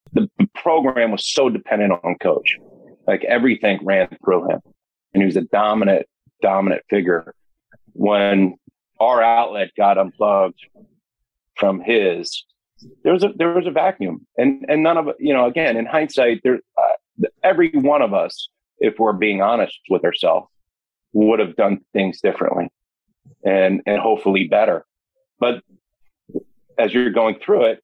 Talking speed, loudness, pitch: 150 wpm, -18 LUFS, 145 Hz